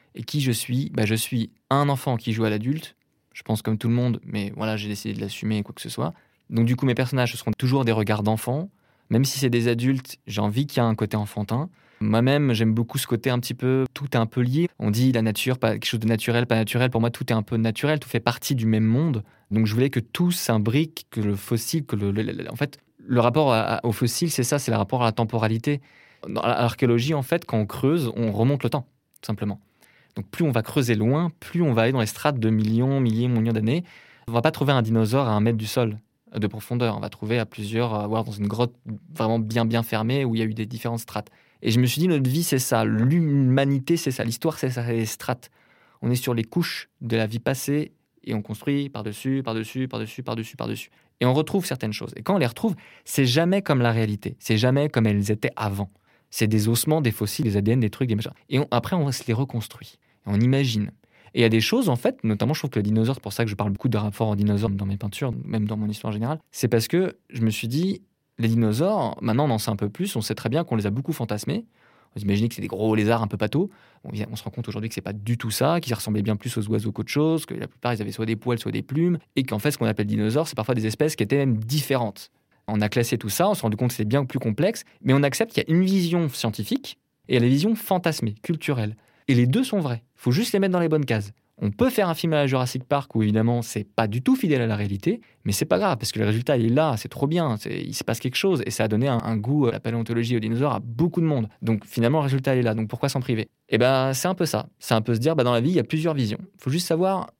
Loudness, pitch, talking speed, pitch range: -24 LUFS, 120 Hz, 285 wpm, 110-140 Hz